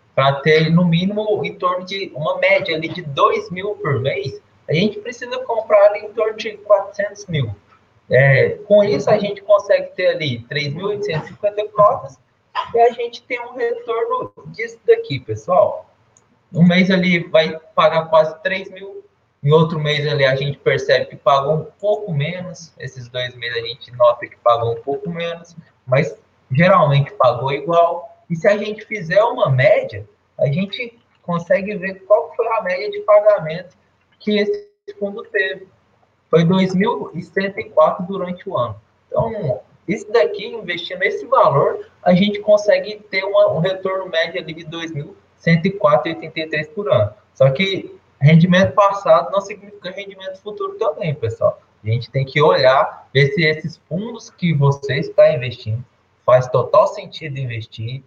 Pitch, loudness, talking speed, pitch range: 180 Hz, -17 LUFS, 155 wpm, 145-210 Hz